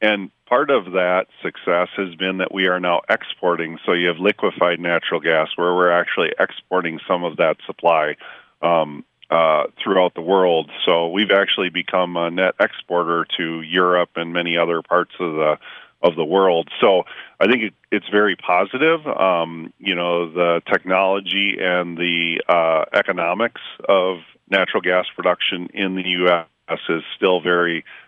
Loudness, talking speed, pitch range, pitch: -19 LUFS, 160 wpm, 85-95 Hz, 90 Hz